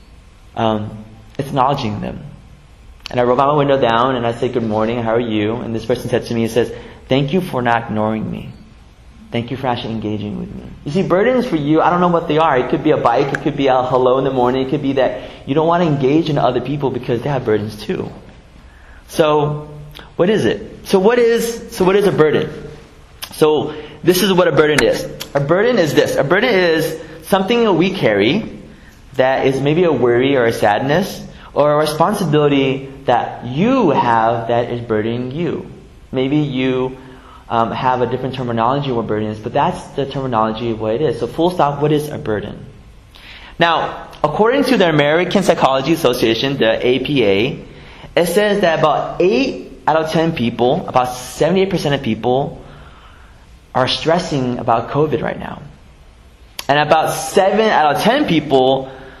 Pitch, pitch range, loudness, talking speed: 135 Hz, 115-160 Hz, -16 LUFS, 190 wpm